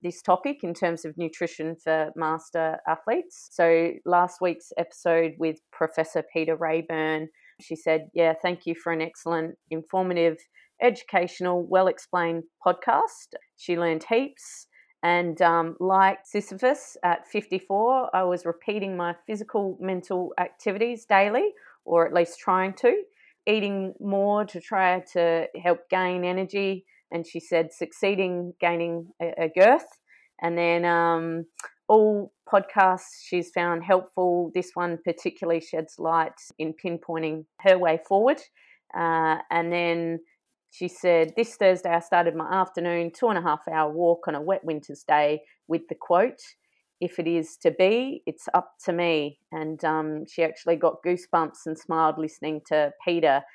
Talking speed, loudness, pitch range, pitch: 145 wpm, -25 LUFS, 165-190 Hz, 175 Hz